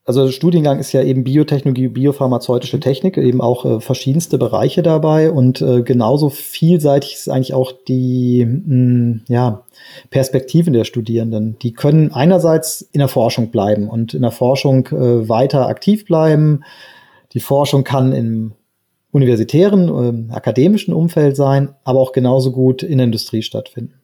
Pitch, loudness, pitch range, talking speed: 130 Hz, -14 LUFS, 125-145 Hz, 150 wpm